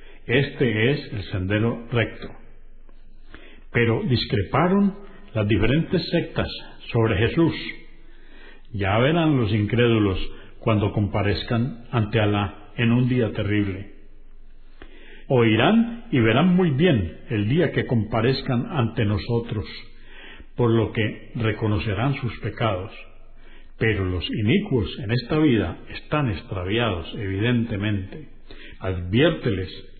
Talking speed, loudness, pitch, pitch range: 100 wpm, -23 LUFS, 115 Hz, 105-125 Hz